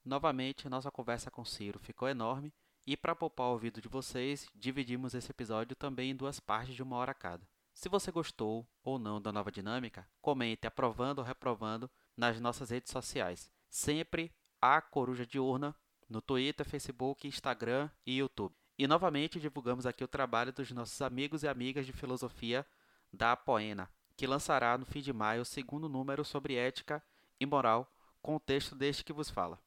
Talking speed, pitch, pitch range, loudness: 180 wpm, 130 Hz, 120-140 Hz, -37 LUFS